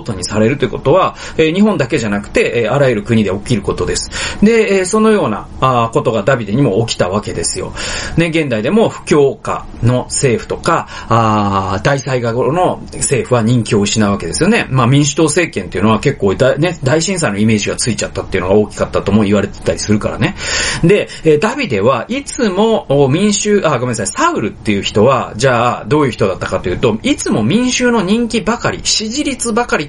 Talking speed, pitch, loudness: 425 characters per minute, 130 Hz, -13 LUFS